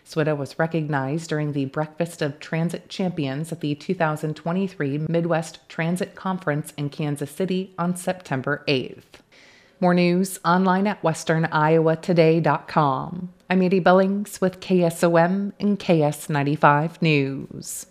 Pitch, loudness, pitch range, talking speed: 165 Hz, -22 LUFS, 150-185 Hz, 115 wpm